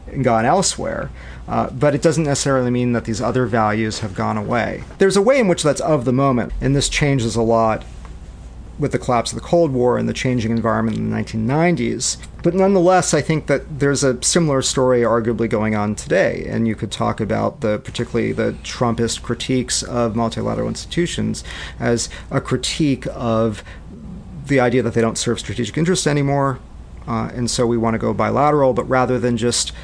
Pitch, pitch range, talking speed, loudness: 120 Hz, 110-140 Hz, 190 wpm, -18 LUFS